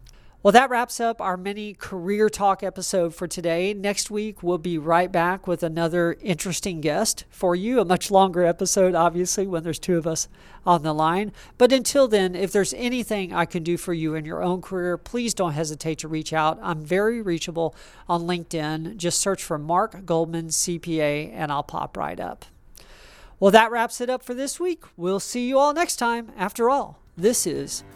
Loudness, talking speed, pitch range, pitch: -23 LUFS, 195 wpm, 170-210 Hz, 180 Hz